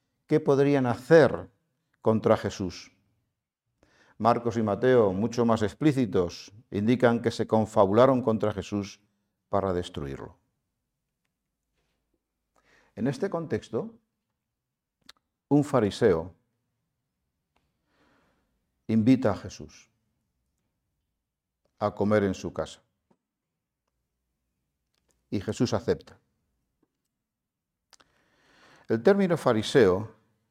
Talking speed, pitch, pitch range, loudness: 75 wpm, 110 Hz, 100-125 Hz, -26 LUFS